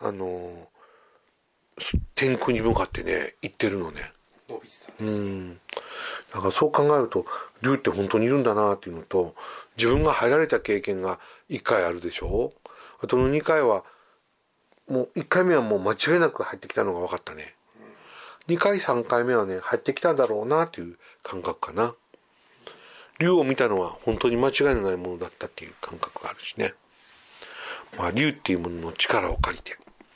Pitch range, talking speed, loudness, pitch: 90-135 Hz, 320 characters per minute, -25 LUFS, 110 Hz